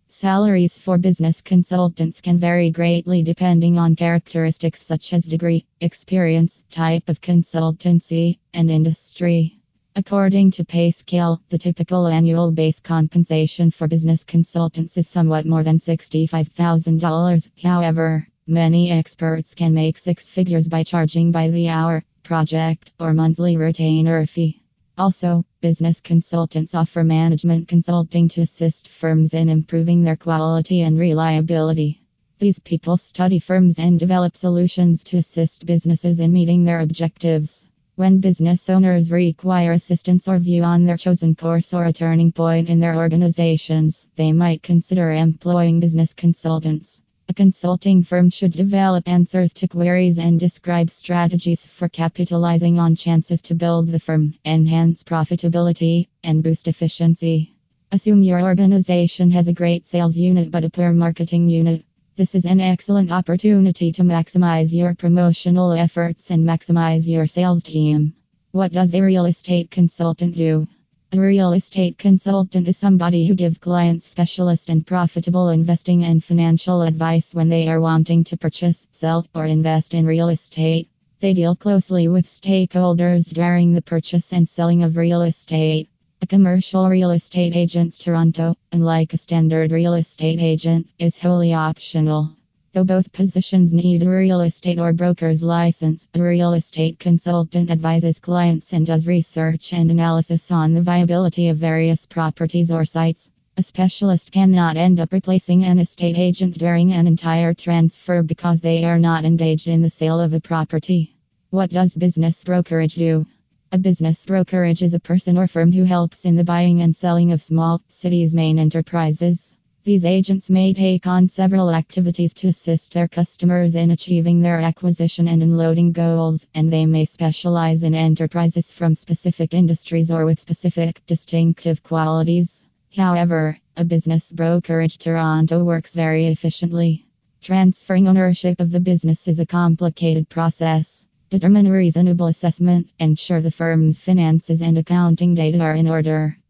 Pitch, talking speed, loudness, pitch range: 170 Hz, 150 wpm, -17 LUFS, 165-175 Hz